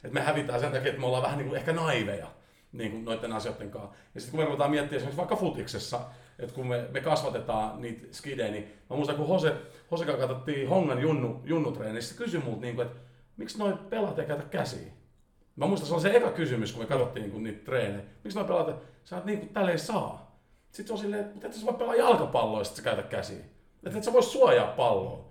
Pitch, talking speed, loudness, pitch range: 140 Hz, 235 wpm, -30 LUFS, 120-175 Hz